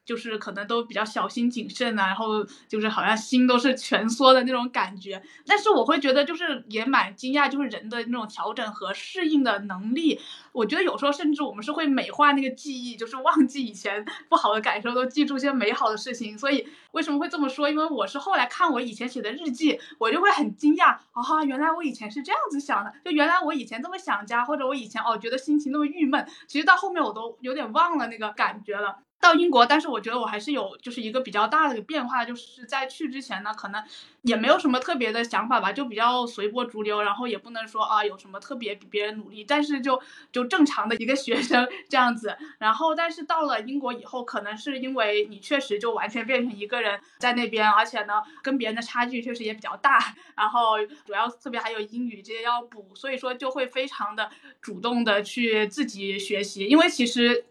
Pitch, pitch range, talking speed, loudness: 245 Hz, 220-285 Hz, 345 characters per minute, -25 LUFS